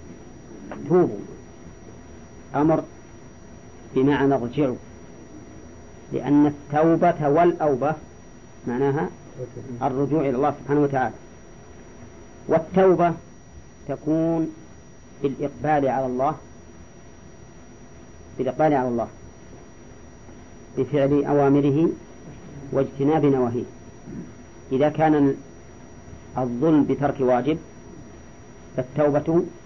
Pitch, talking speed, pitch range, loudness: 140 Hz, 65 wpm, 125-150 Hz, -22 LUFS